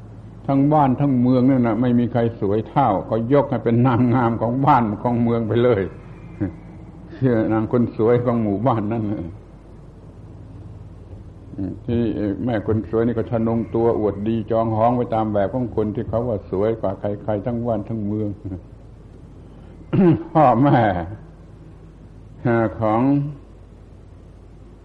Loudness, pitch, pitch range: -20 LUFS, 110 Hz, 105-120 Hz